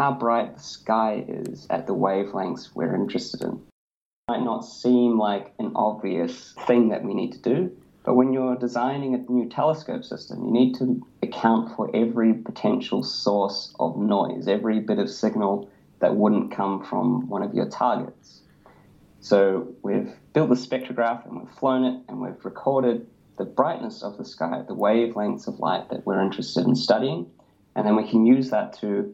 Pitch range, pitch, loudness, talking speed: 105-125 Hz, 120 Hz, -24 LUFS, 180 wpm